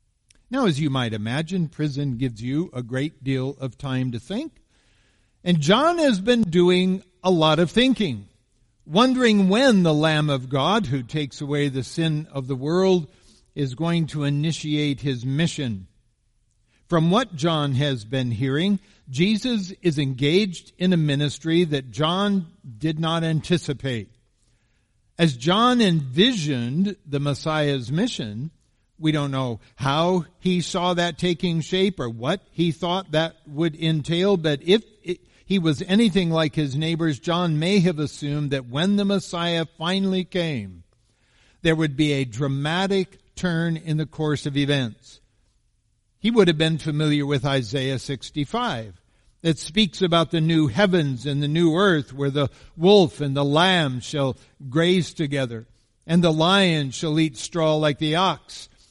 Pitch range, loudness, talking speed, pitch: 135-180 Hz, -22 LUFS, 150 wpm, 155 Hz